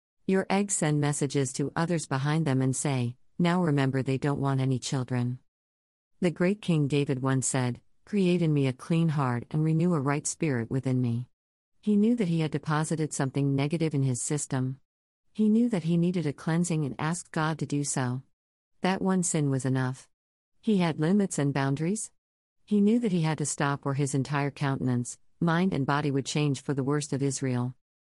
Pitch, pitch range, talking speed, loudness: 145 Hz, 135-170 Hz, 195 wpm, -28 LUFS